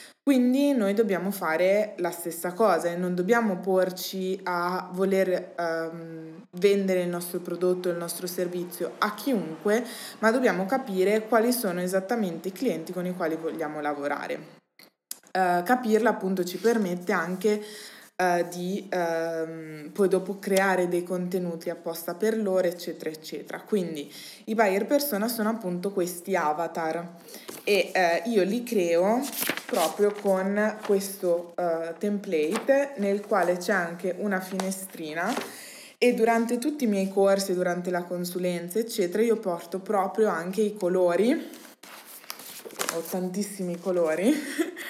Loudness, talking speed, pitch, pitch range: -27 LUFS, 130 wpm, 190 Hz, 175-215 Hz